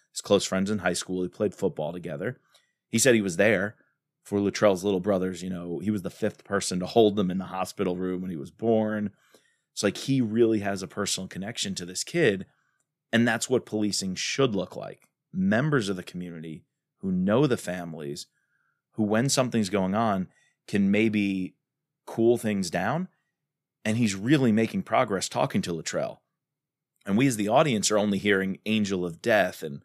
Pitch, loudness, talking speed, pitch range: 105 Hz, -26 LUFS, 185 wpm, 95-120 Hz